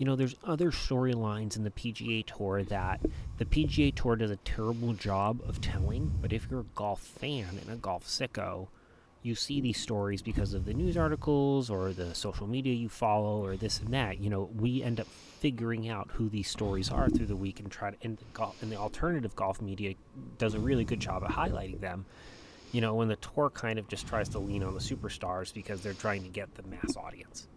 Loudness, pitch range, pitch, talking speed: -33 LUFS, 100-120 Hz, 110 Hz, 220 wpm